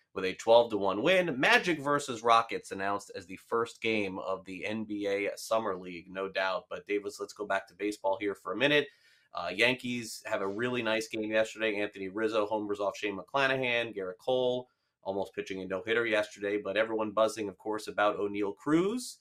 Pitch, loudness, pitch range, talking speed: 110 Hz, -31 LUFS, 100-125 Hz, 195 wpm